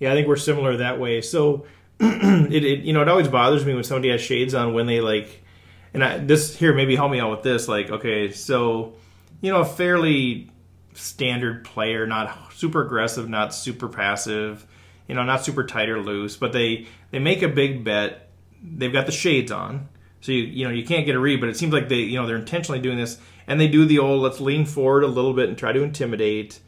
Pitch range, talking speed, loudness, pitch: 110-145 Hz, 230 wpm, -21 LUFS, 125 Hz